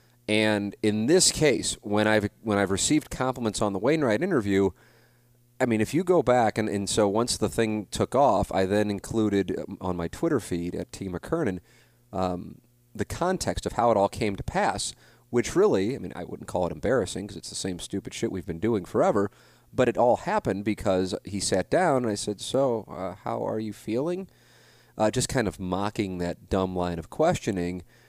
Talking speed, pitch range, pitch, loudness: 200 wpm, 95-120 Hz, 105 Hz, -26 LUFS